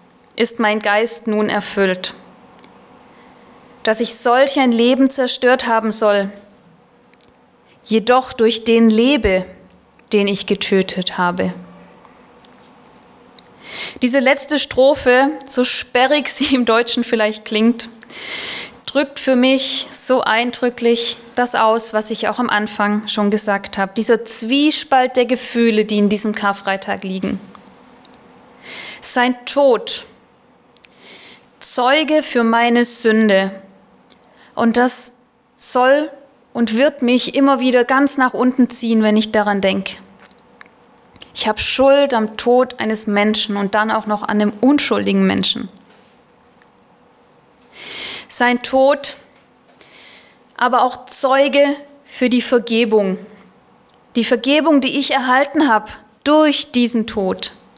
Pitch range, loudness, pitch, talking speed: 215-255 Hz, -15 LUFS, 235 Hz, 115 wpm